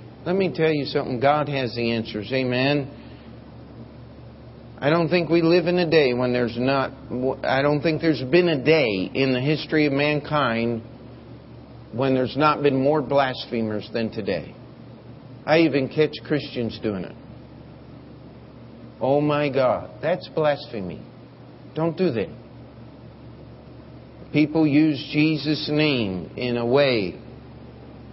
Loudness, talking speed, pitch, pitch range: -22 LUFS, 130 wpm, 135 Hz, 120-150 Hz